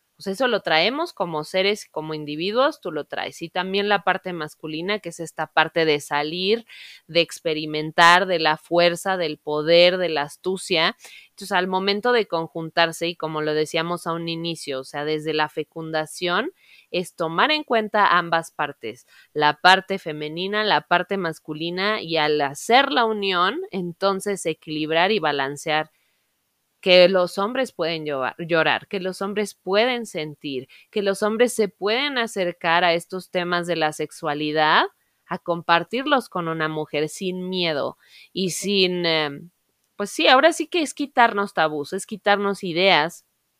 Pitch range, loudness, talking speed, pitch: 155-195 Hz, -22 LUFS, 155 wpm, 175 Hz